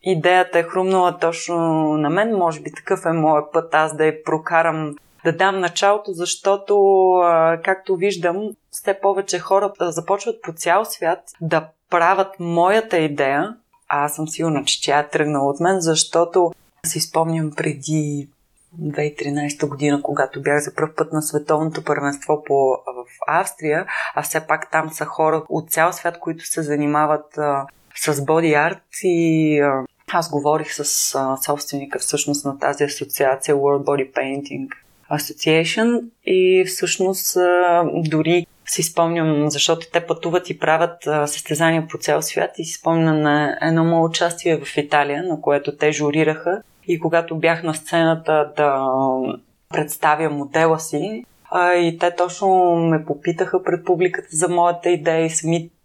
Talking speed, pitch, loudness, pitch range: 150 wpm, 160 Hz, -19 LUFS, 150-175 Hz